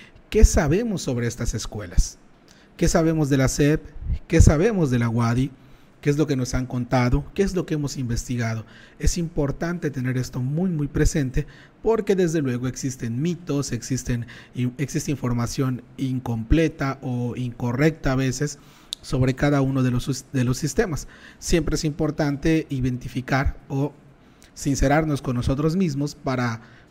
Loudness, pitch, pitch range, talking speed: -24 LUFS, 135 Hz, 125-155 Hz, 145 wpm